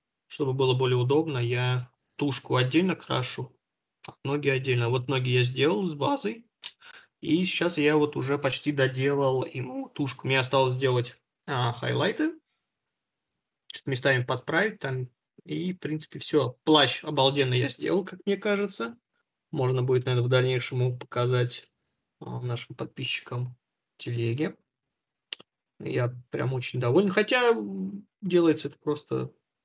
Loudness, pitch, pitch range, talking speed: -27 LUFS, 135 Hz, 125-160 Hz, 120 wpm